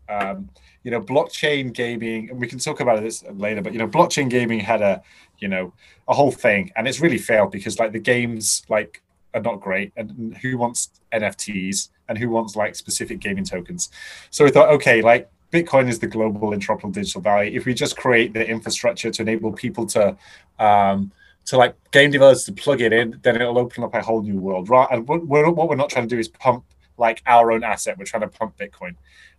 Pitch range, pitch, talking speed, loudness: 110-130 Hz, 115 Hz, 215 wpm, -19 LUFS